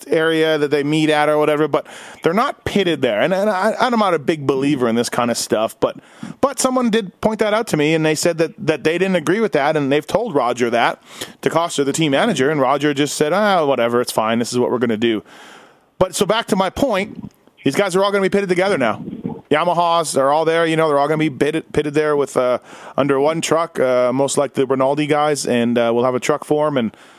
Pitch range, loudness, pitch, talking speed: 140-185 Hz, -17 LUFS, 155 Hz, 265 wpm